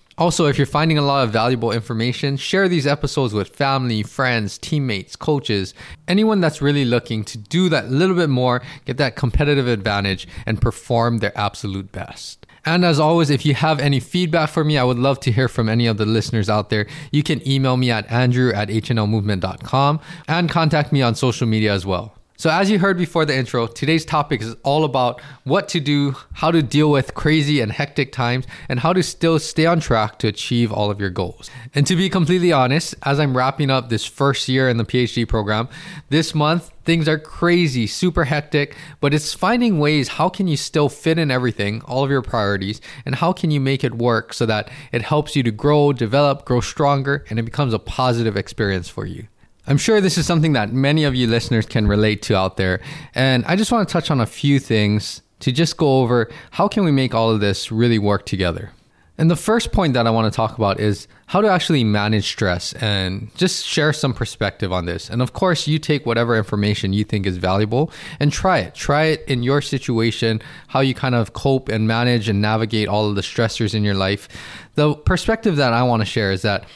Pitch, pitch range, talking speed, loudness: 130 Hz, 110-150 Hz, 220 wpm, -19 LUFS